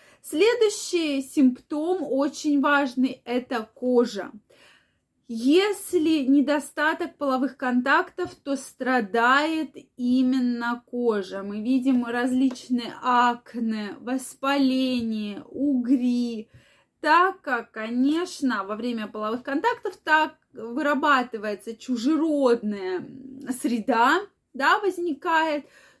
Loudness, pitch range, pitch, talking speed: -24 LUFS, 240-305 Hz, 265 Hz, 75 wpm